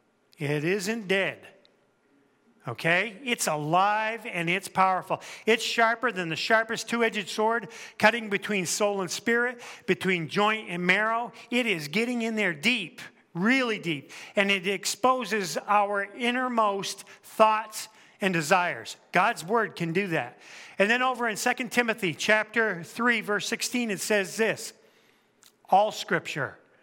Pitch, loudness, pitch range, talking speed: 210 Hz, -26 LUFS, 190-230 Hz, 135 wpm